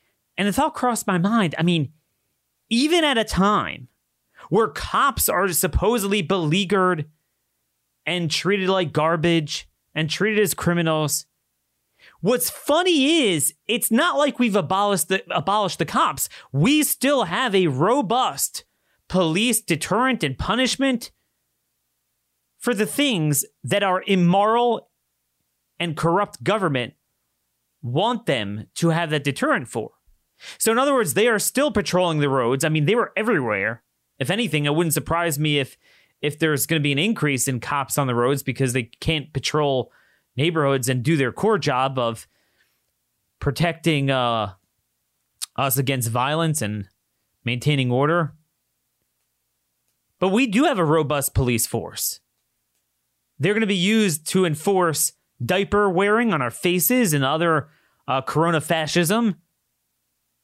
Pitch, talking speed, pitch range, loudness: 160 Hz, 140 wpm, 130-200 Hz, -21 LUFS